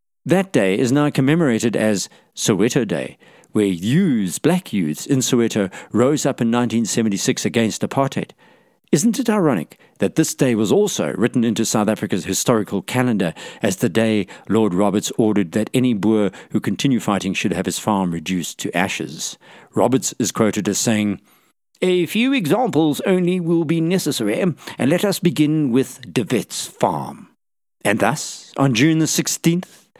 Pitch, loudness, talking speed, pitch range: 125 Hz, -19 LUFS, 160 wpm, 110-160 Hz